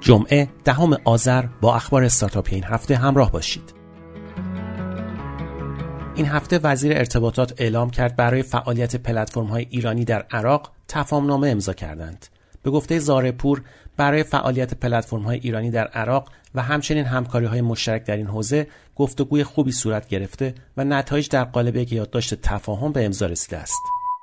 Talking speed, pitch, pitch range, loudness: 145 wpm, 125 Hz, 110-140 Hz, -21 LUFS